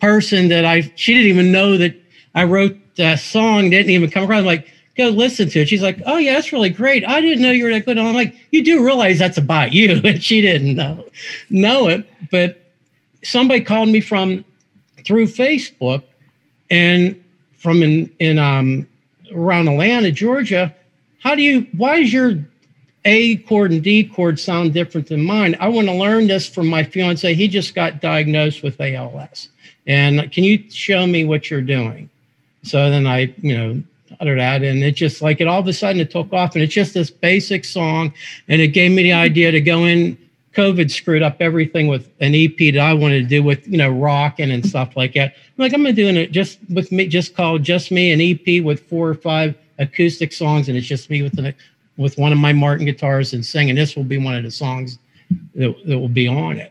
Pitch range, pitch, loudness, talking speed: 145-195 Hz, 170 Hz, -15 LUFS, 215 wpm